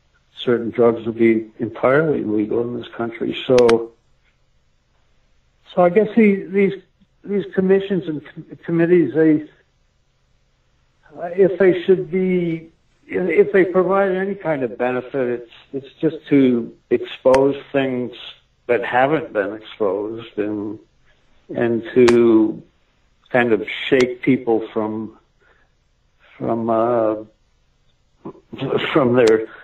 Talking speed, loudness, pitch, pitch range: 110 wpm, -18 LUFS, 135 Hz, 115-185 Hz